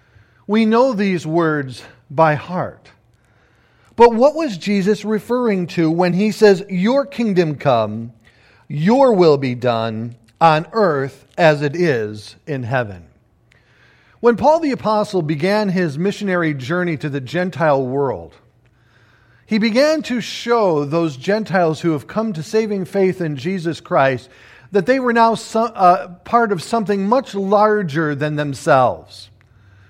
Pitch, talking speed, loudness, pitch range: 170 Hz, 140 wpm, -17 LUFS, 130-210 Hz